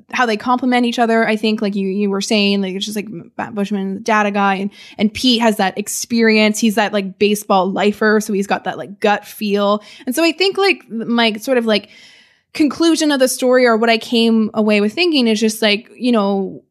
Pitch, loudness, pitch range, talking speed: 215 Hz, -16 LUFS, 205-235 Hz, 230 wpm